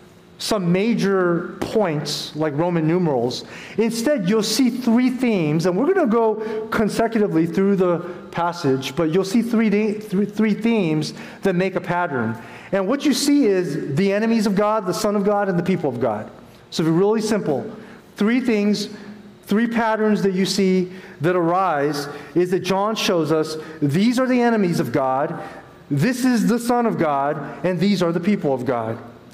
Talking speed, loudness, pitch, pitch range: 175 wpm, -20 LUFS, 195 Hz, 165-220 Hz